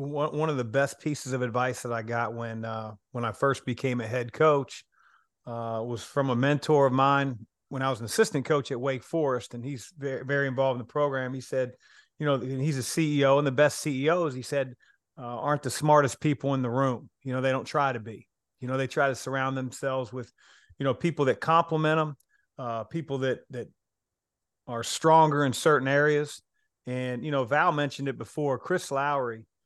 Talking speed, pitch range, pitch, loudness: 210 wpm, 125-145 Hz, 135 Hz, -27 LUFS